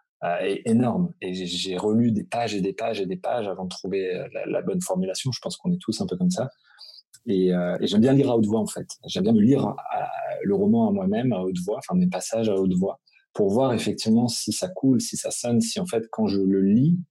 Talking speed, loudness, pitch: 265 wpm, -24 LUFS, 130 Hz